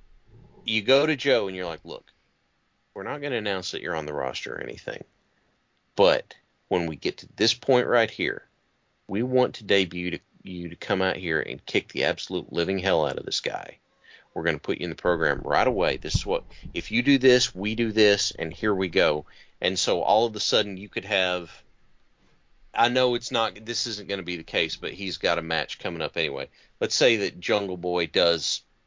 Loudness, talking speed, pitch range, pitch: -25 LUFS, 220 wpm, 90-120 Hz, 105 Hz